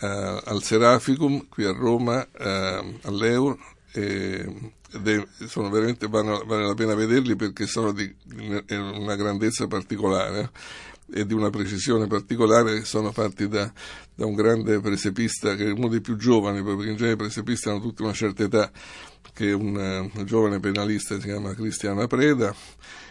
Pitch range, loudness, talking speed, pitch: 100-115 Hz, -24 LUFS, 165 wpm, 105 Hz